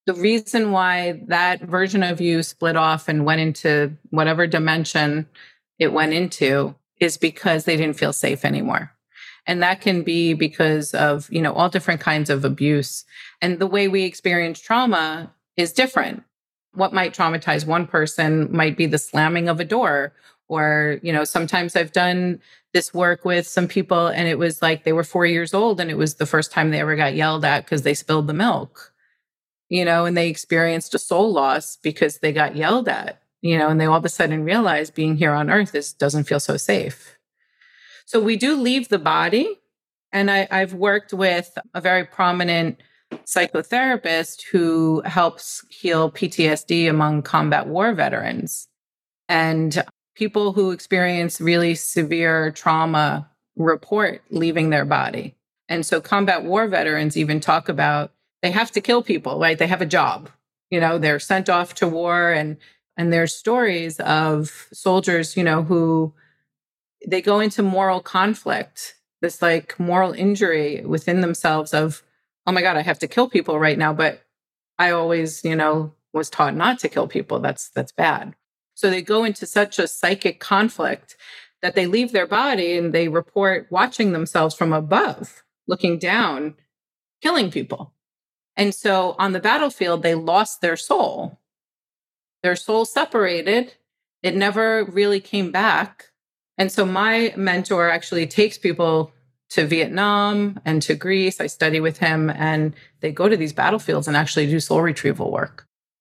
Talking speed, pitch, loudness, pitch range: 170 wpm, 170 Hz, -20 LUFS, 155-190 Hz